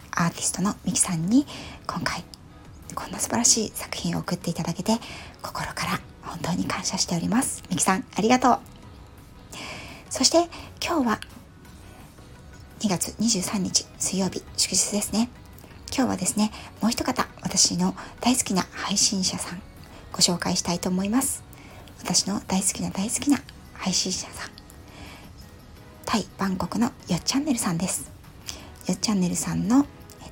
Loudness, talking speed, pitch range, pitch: -24 LUFS, 290 characters per minute, 180-235 Hz, 200 Hz